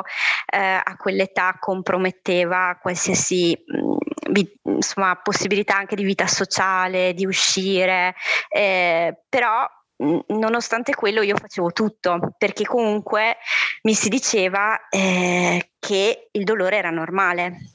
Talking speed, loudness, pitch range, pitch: 105 wpm, -20 LUFS, 180-215 Hz, 195 Hz